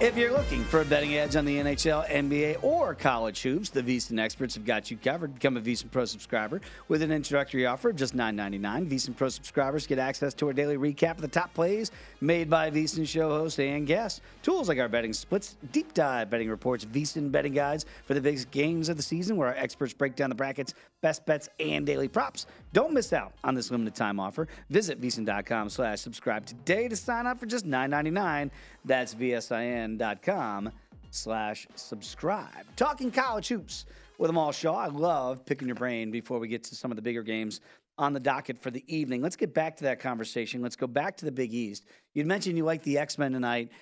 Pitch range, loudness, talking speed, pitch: 120-160 Hz, -30 LUFS, 210 wpm, 140 Hz